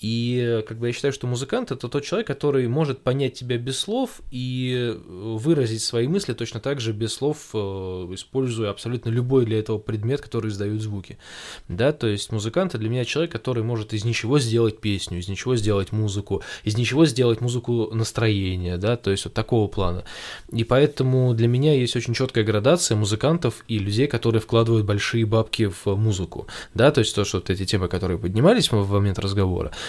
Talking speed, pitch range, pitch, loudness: 185 wpm, 105-125 Hz, 115 Hz, -23 LUFS